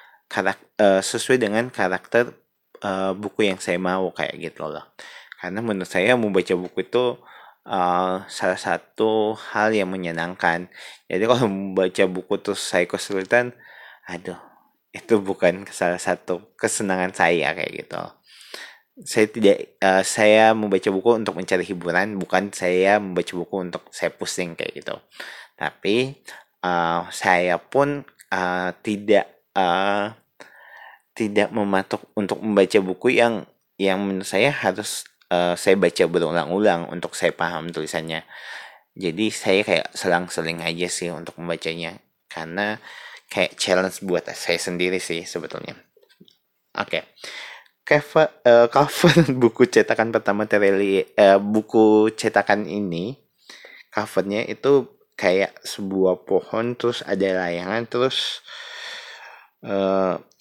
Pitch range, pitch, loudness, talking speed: 90-115 Hz, 100 Hz, -21 LUFS, 120 wpm